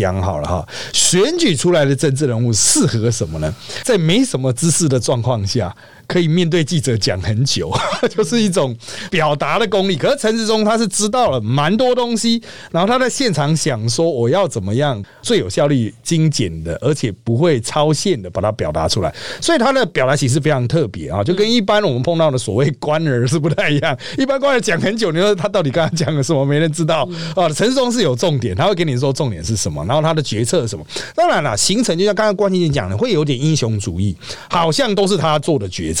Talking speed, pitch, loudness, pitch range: 340 characters per minute, 155 Hz, -16 LUFS, 125-195 Hz